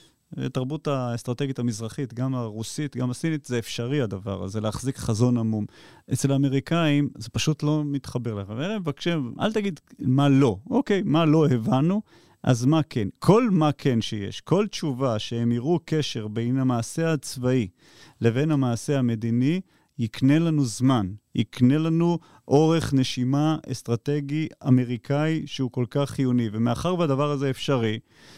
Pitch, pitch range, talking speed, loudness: 135 Hz, 120-150 Hz, 140 wpm, -24 LUFS